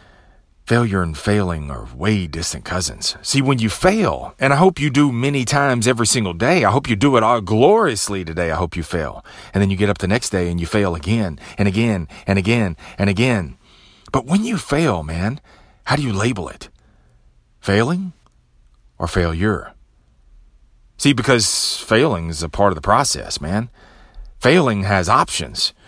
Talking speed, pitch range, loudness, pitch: 180 wpm, 85-125 Hz, -18 LUFS, 105 Hz